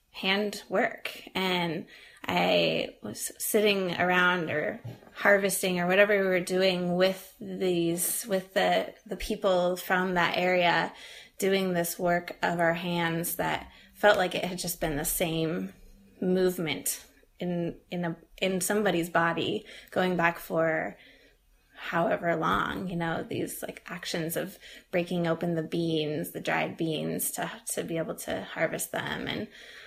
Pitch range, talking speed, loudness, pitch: 170-190 Hz, 145 wpm, -28 LUFS, 180 Hz